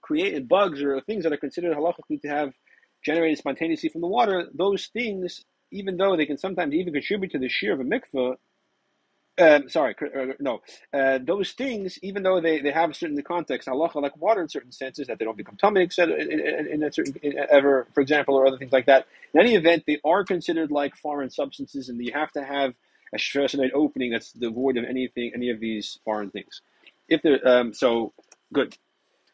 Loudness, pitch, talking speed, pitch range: -24 LUFS, 145 Hz, 210 wpm, 135-175 Hz